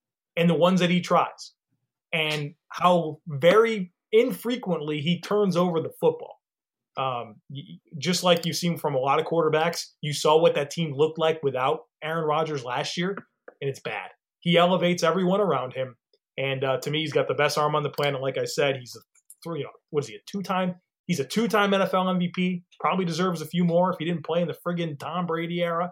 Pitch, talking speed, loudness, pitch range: 165 Hz, 215 wpm, -25 LUFS, 150-180 Hz